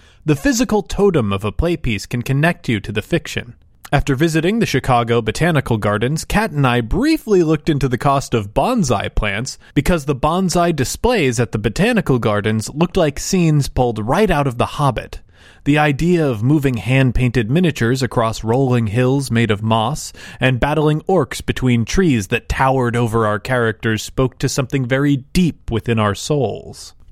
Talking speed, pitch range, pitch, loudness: 170 wpm, 115-155 Hz, 130 Hz, -17 LUFS